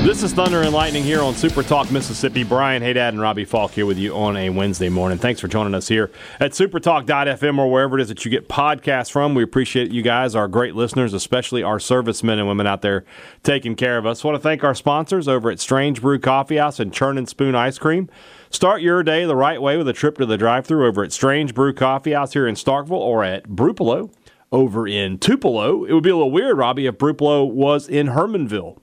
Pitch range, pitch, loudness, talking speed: 115-150 Hz, 135 Hz, -18 LUFS, 230 wpm